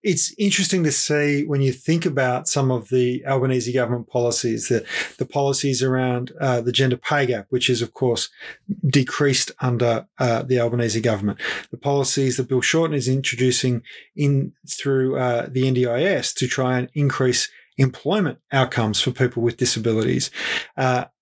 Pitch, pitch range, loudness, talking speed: 130 Hz, 125-140 Hz, -21 LUFS, 160 wpm